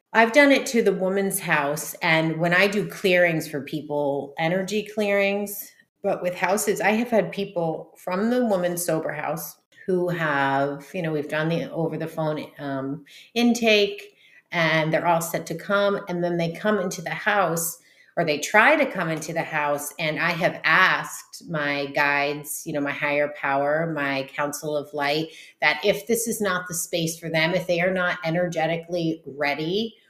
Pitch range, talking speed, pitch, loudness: 150-195 Hz, 180 wpm, 165 Hz, -23 LUFS